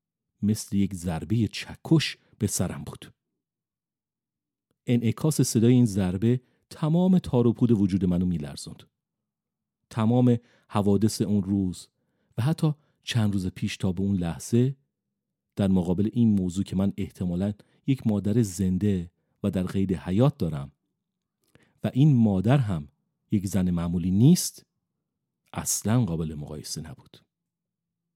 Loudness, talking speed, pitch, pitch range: -25 LUFS, 120 wpm, 105 Hz, 95-125 Hz